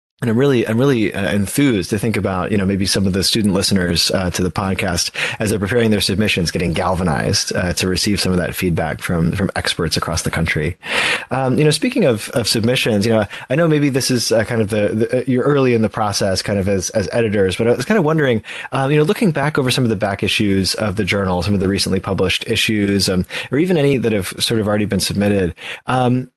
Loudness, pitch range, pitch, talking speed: -17 LUFS, 95-120 Hz, 105 Hz, 245 wpm